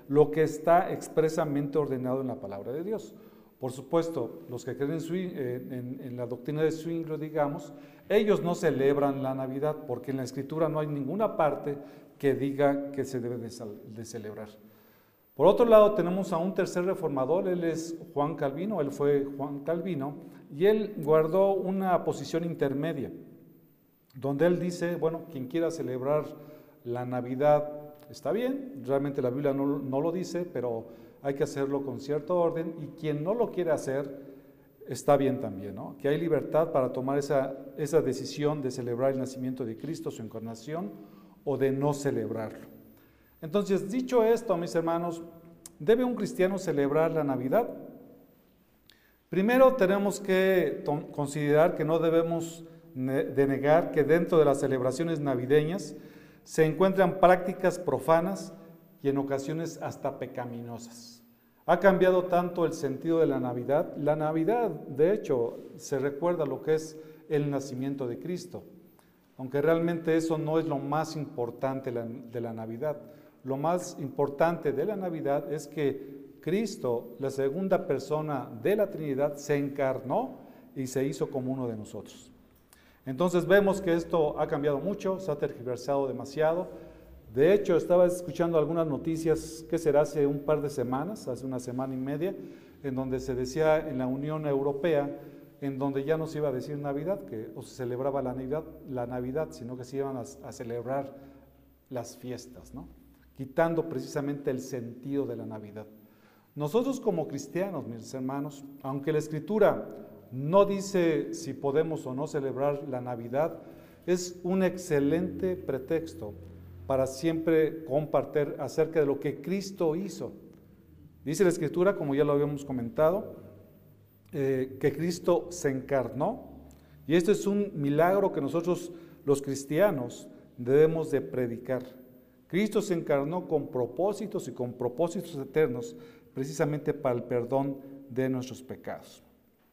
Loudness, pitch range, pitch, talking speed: -29 LUFS, 135-165 Hz, 145 Hz, 150 wpm